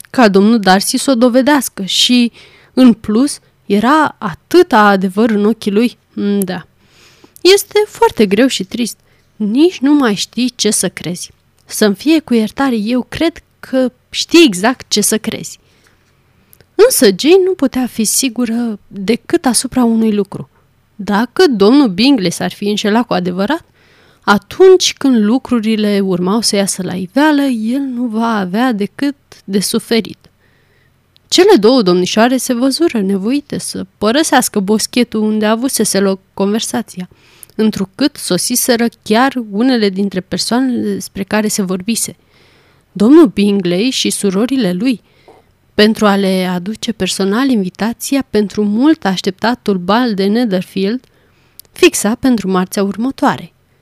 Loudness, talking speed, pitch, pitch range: -13 LUFS, 130 wpm, 220 Hz, 195-255 Hz